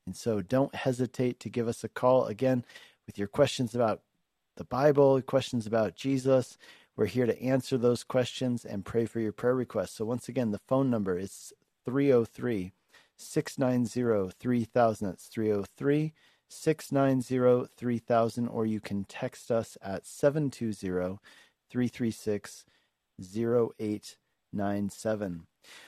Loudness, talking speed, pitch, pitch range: -30 LUFS, 125 wpm, 120 Hz, 110-130 Hz